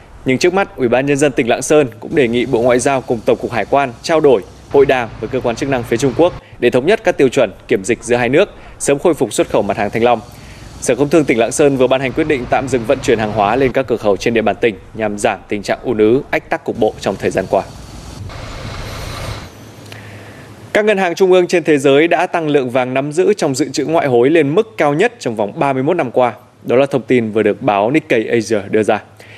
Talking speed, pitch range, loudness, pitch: 270 wpm, 110-145 Hz, -14 LUFS, 125 Hz